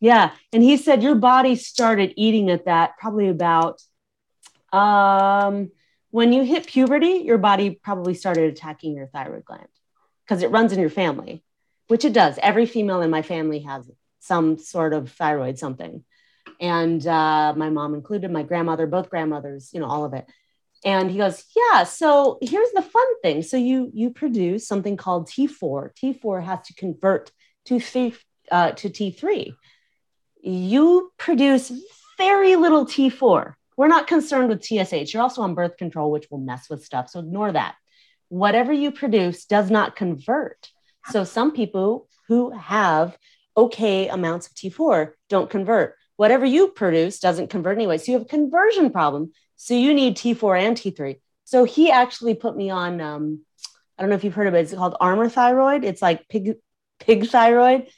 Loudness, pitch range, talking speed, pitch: -20 LUFS, 170-250 Hz, 170 wpm, 200 Hz